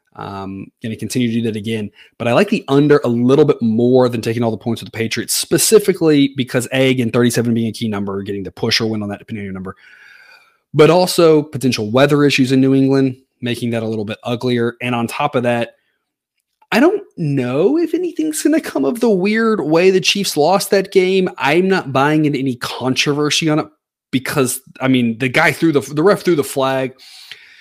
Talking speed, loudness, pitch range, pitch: 215 wpm, -15 LUFS, 115-160 Hz, 130 Hz